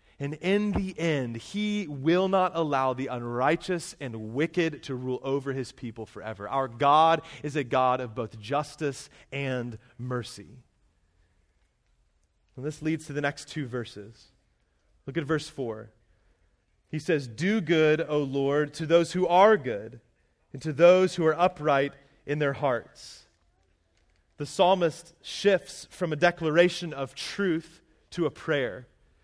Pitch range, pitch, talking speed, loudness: 120-165 Hz, 145 Hz, 145 wpm, -27 LUFS